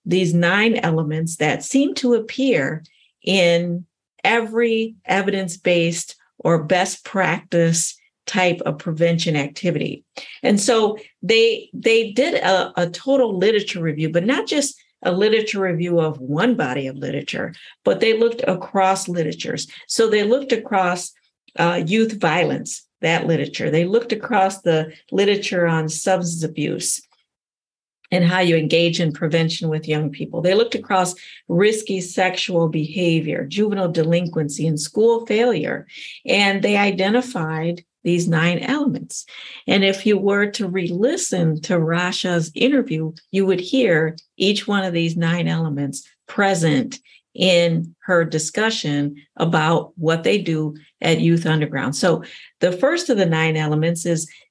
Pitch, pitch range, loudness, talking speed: 180 Hz, 165-215 Hz, -19 LUFS, 135 wpm